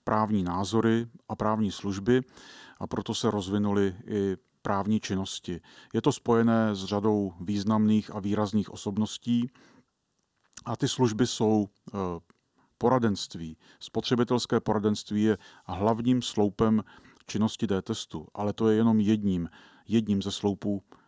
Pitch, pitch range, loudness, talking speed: 105 Hz, 100-115 Hz, -28 LUFS, 115 wpm